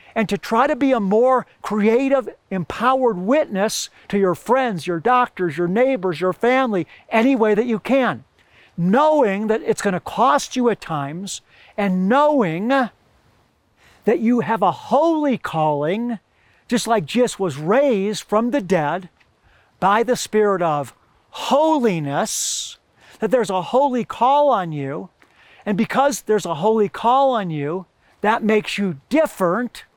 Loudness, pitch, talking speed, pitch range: -19 LUFS, 220 Hz, 145 wpm, 185-255 Hz